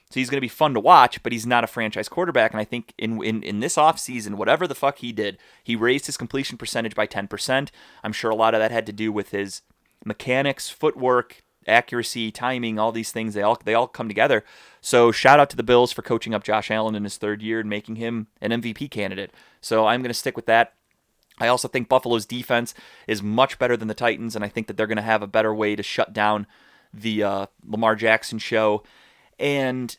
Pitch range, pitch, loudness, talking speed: 110-120 Hz, 115 Hz, -22 LUFS, 235 wpm